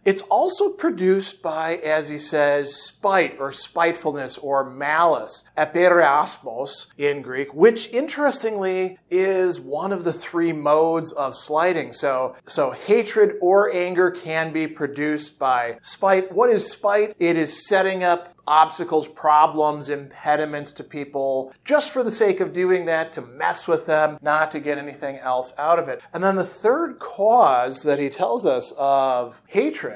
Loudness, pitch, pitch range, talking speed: -21 LUFS, 160 Hz, 145-190 Hz, 155 wpm